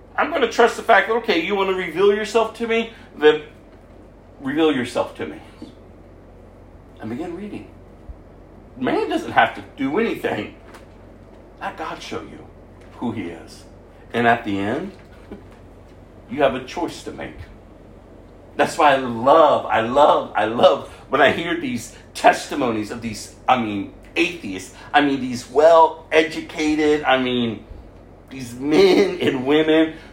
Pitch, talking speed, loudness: 120 Hz, 145 wpm, -19 LUFS